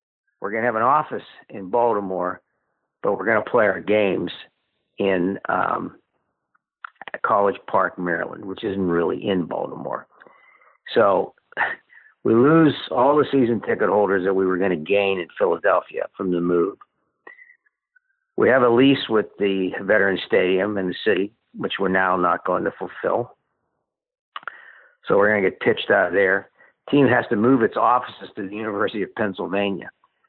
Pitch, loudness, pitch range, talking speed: 105 Hz, -21 LUFS, 95-150 Hz, 165 wpm